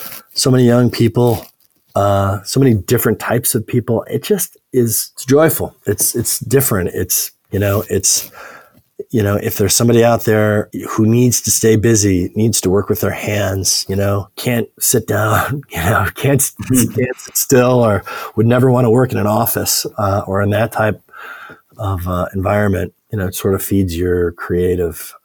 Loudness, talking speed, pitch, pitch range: -15 LUFS, 185 wpm, 105 Hz, 100-120 Hz